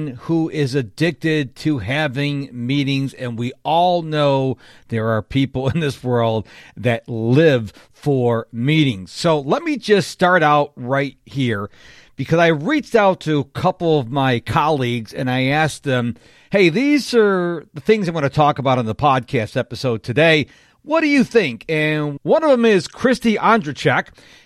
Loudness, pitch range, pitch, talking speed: -18 LUFS, 125-165 Hz, 145 Hz, 165 wpm